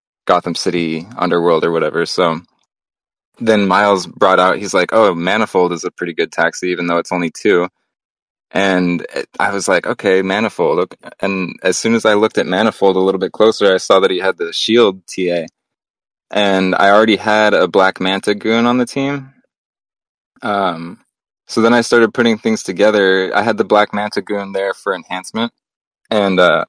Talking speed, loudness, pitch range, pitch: 185 wpm, -14 LUFS, 90-110 Hz, 100 Hz